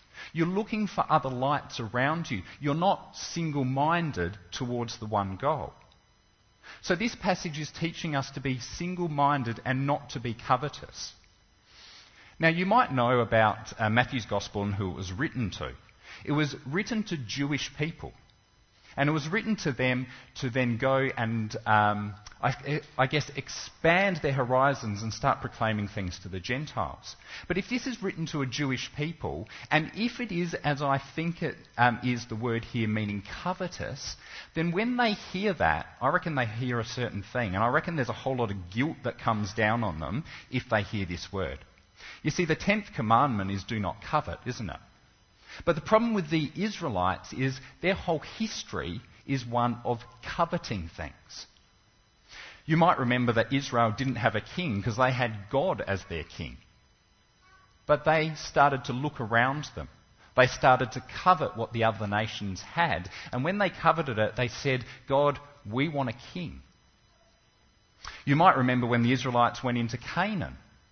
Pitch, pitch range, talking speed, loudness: 130 Hz, 110-155 Hz, 175 wpm, -29 LUFS